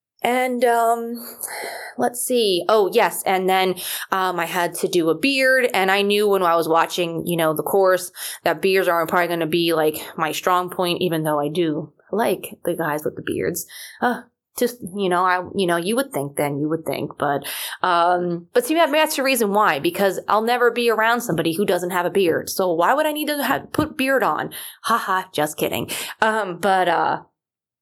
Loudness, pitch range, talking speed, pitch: -20 LUFS, 170-230 Hz, 205 wpm, 185 Hz